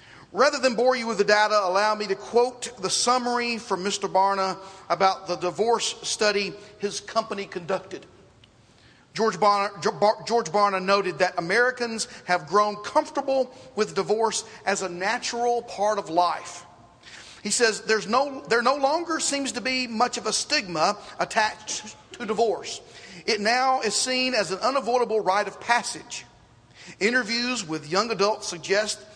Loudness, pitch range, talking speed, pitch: -24 LUFS, 195-240 Hz, 150 wpm, 210 Hz